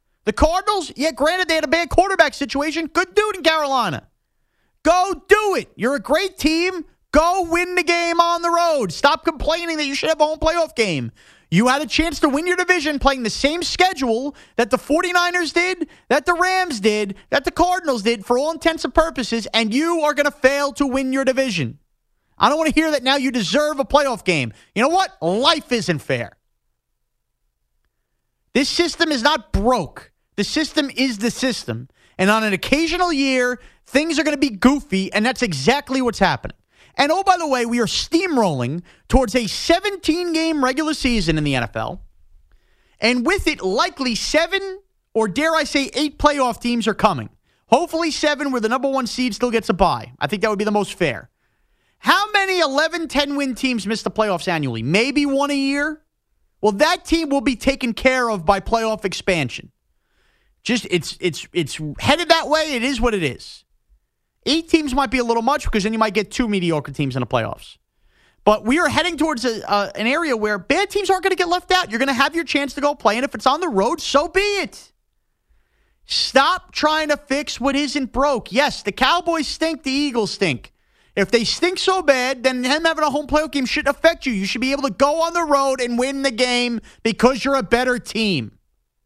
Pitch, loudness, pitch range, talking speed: 275 Hz, -19 LUFS, 225-320 Hz, 210 wpm